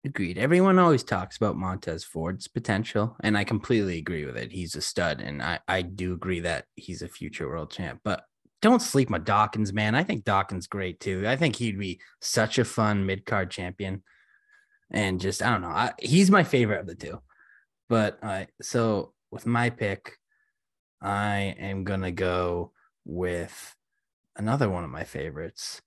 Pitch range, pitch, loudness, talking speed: 95-120 Hz, 105 Hz, -27 LUFS, 180 wpm